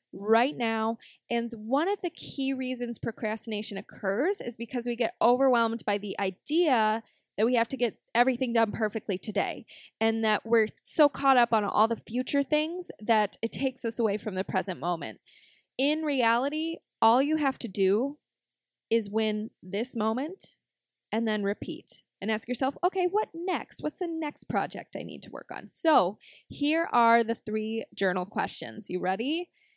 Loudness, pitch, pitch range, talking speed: -28 LUFS, 230 Hz, 215-275 Hz, 170 wpm